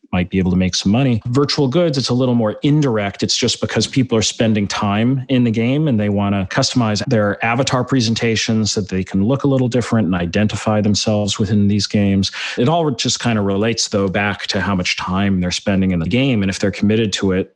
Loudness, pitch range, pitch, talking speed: -17 LUFS, 100-125 Hz, 110 Hz, 230 wpm